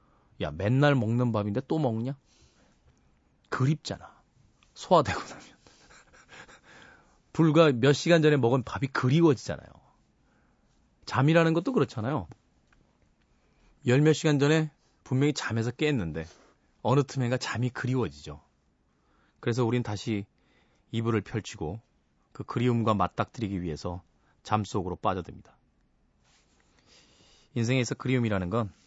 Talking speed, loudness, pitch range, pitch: 255 characters per minute, -27 LUFS, 90-135 Hz, 115 Hz